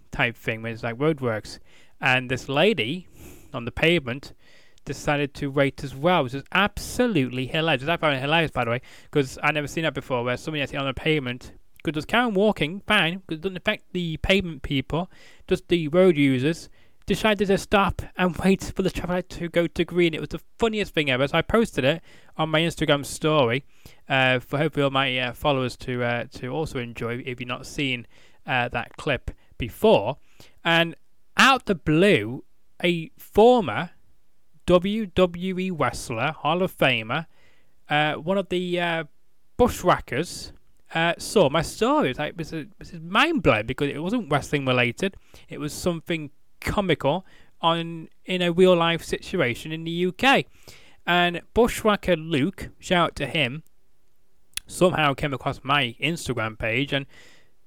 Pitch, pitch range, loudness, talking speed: 155 Hz, 135-180 Hz, -23 LUFS, 170 wpm